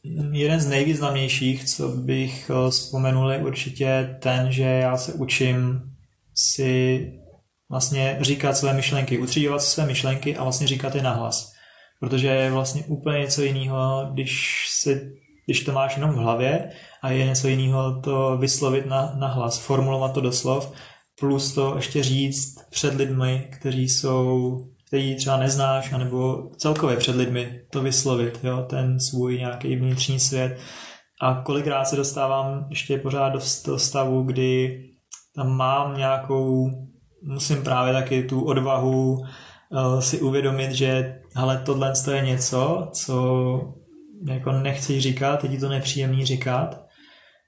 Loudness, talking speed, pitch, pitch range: -23 LUFS, 135 wpm, 135 Hz, 130-140 Hz